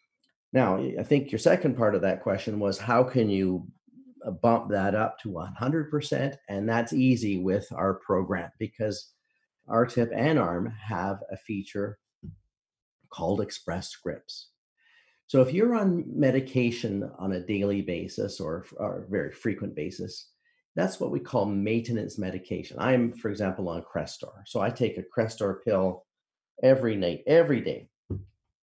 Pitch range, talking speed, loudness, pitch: 95-125 Hz, 145 wpm, -28 LUFS, 110 Hz